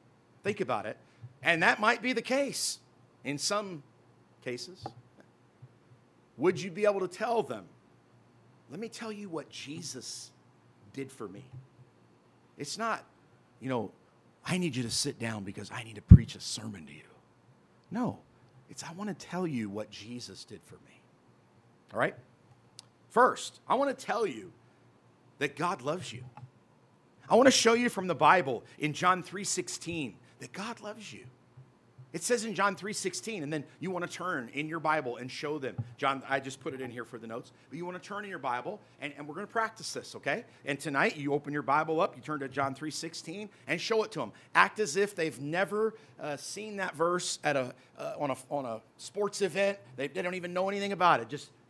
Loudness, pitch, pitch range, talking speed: -31 LUFS, 150 Hz, 125-185 Hz, 200 wpm